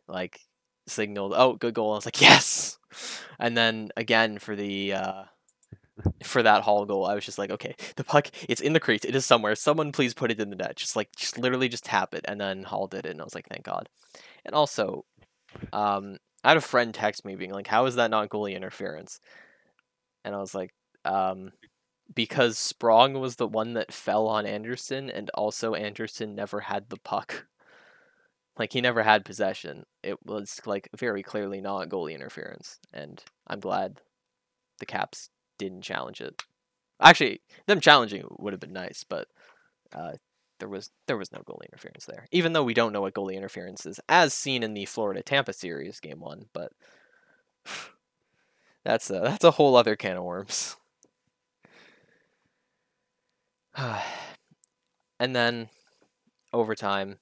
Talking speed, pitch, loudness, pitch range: 175 wpm, 110 Hz, -25 LUFS, 100-125 Hz